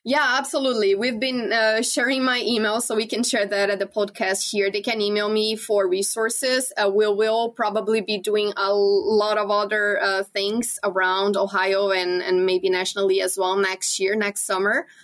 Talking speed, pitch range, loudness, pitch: 190 wpm, 195-220 Hz, -21 LUFS, 210 Hz